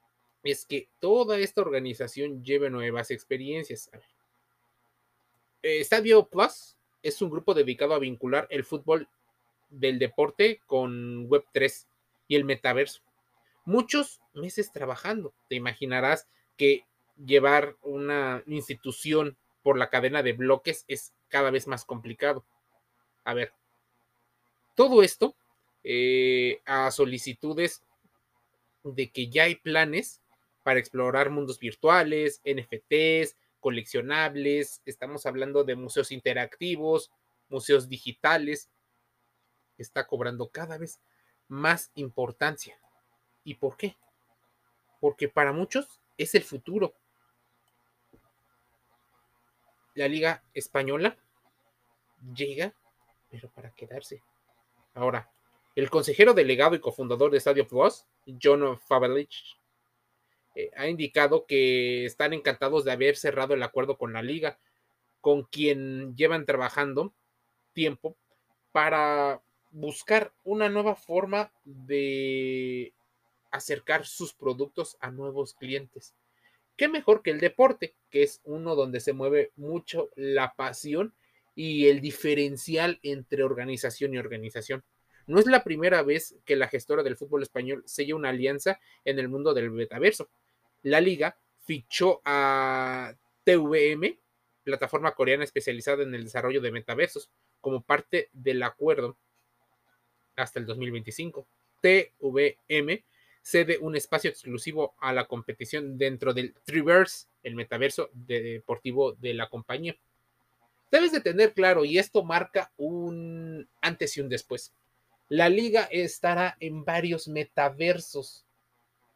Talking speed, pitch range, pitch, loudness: 115 wpm, 125-165 Hz, 140 Hz, -27 LUFS